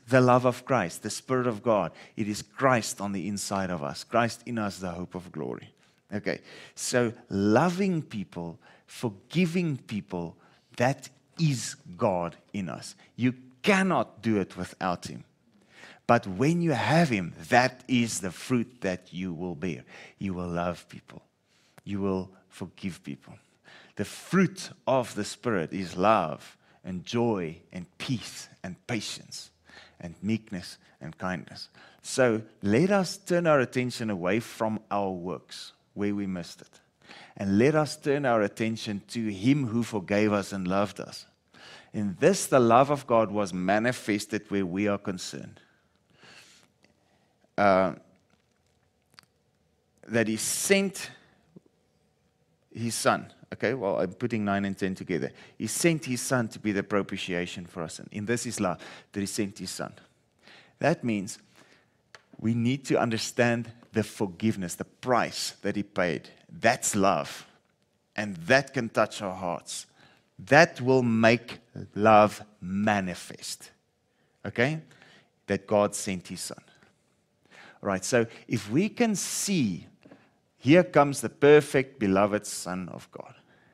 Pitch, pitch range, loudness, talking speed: 110 Hz, 95-125 Hz, -27 LUFS, 145 wpm